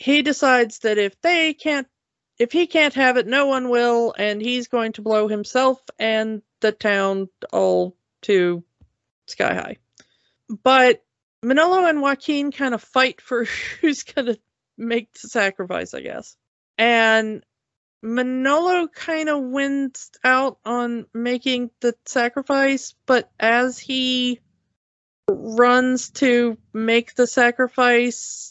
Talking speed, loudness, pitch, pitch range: 130 wpm, -20 LUFS, 245 Hz, 225-275 Hz